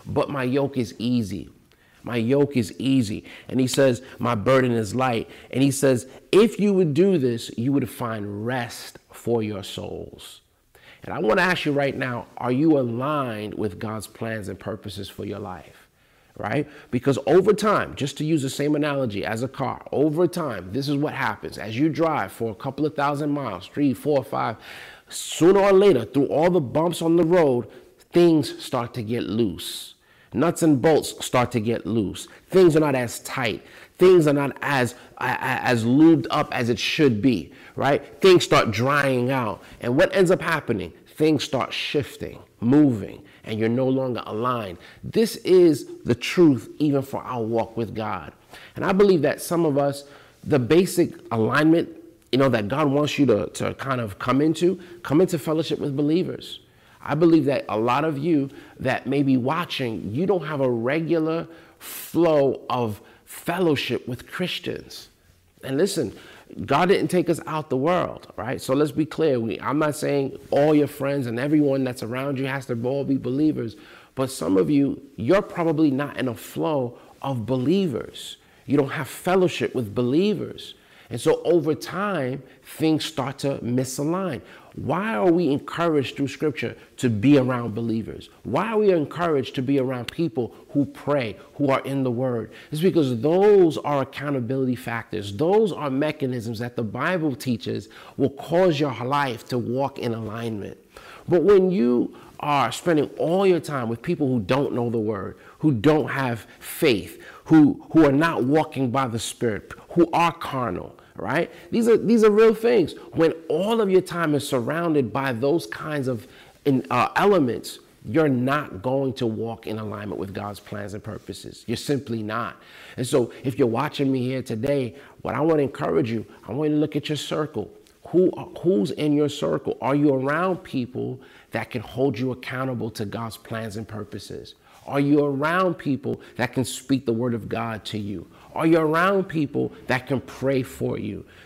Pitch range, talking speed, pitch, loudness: 120-155 Hz, 180 wpm, 135 Hz, -23 LUFS